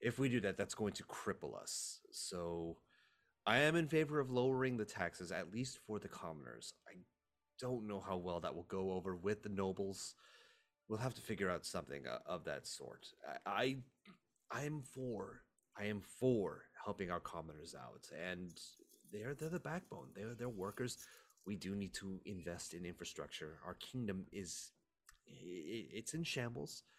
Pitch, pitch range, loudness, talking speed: 105 Hz, 90-125 Hz, -44 LUFS, 170 wpm